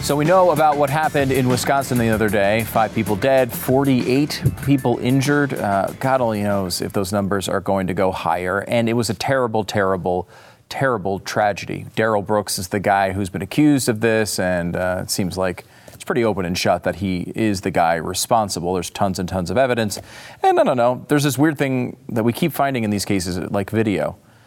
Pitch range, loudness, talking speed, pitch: 100-135 Hz, -19 LUFS, 210 wpm, 110 Hz